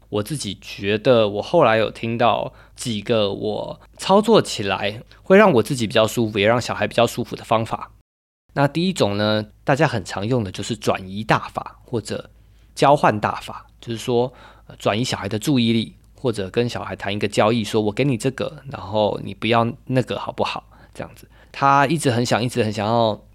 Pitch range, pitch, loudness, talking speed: 105-125 Hz, 115 Hz, -20 LUFS, 285 characters per minute